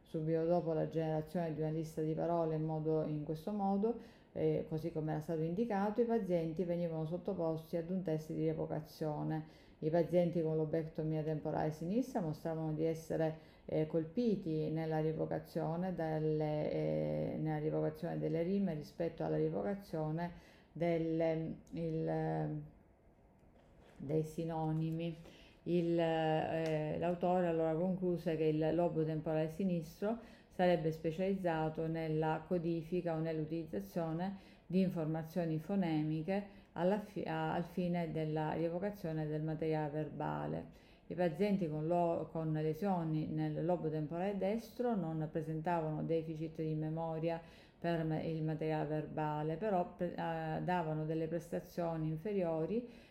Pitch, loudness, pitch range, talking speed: 160 Hz, -38 LUFS, 155-175 Hz, 125 wpm